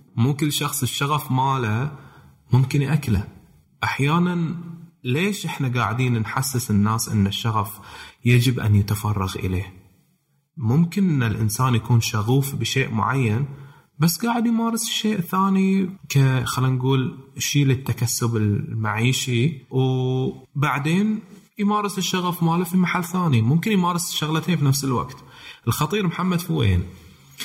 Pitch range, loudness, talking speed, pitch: 120-170 Hz, -22 LUFS, 115 wpm, 135 Hz